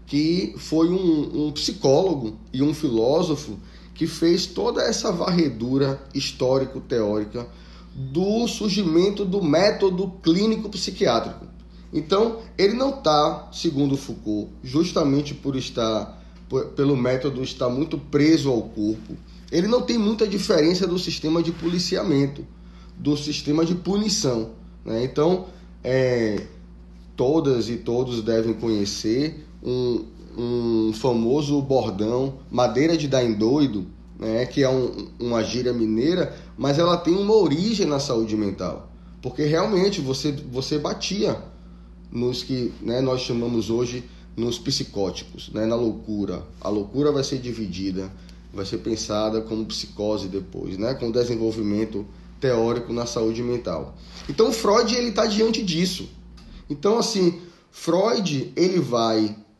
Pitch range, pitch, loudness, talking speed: 110-170 Hz, 135 Hz, -23 LUFS, 125 wpm